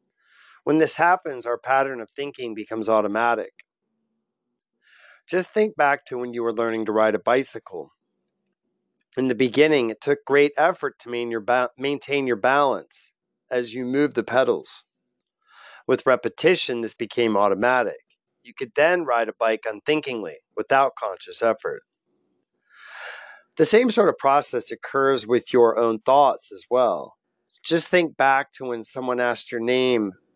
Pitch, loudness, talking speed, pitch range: 130 Hz, -22 LUFS, 145 wpm, 115-155 Hz